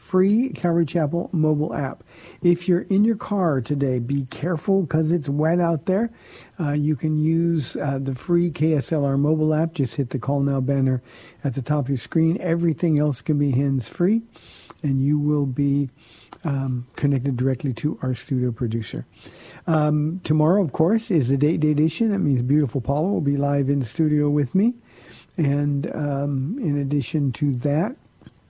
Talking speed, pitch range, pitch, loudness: 175 wpm, 140-170 Hz, 150 Hz, -22 LUFS